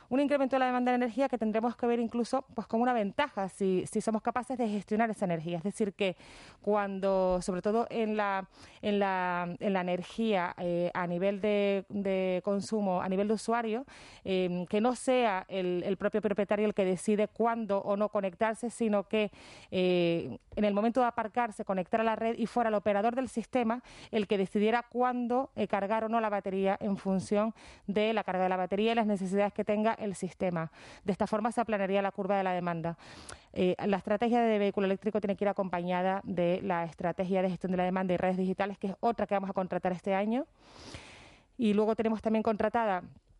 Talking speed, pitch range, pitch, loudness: 210 wpm, 190-225 Hz, 205 Hz, -31 LUFS